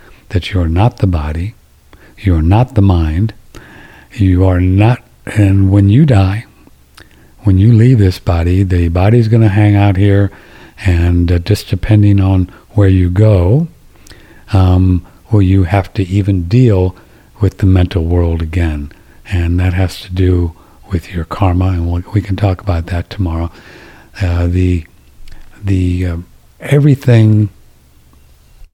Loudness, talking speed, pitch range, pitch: -12 LUFS, 150 wpm, 85-105 Hz, 95 Hz